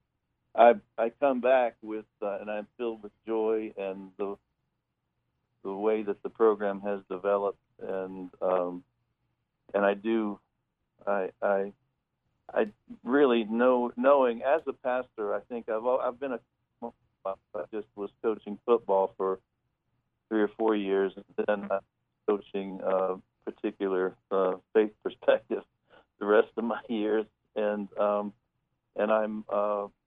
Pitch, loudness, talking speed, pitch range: 105 Hz, -29 LUFS, 150 wpm, 100-115 Hz